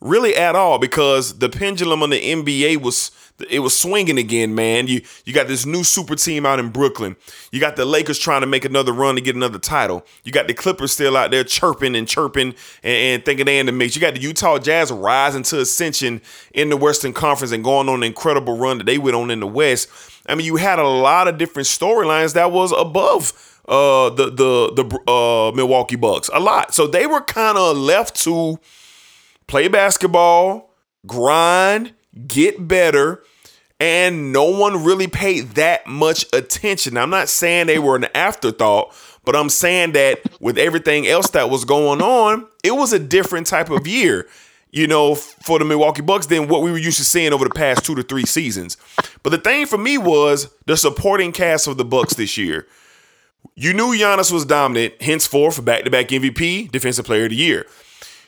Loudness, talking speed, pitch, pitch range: -16 LUFS, 205 wpm, 150 Hz, 130-180 Hz